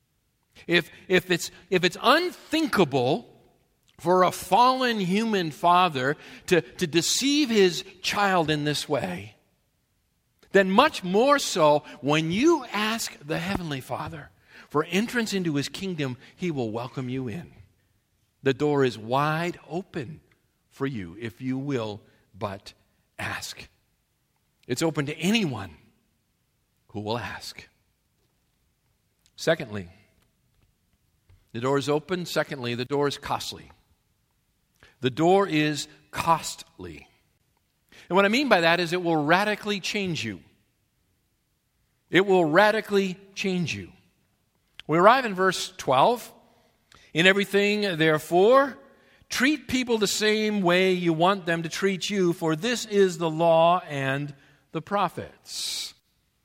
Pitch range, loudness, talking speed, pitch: 130-195 Hz, -24 LUFS, 125 wpm, 165 Hz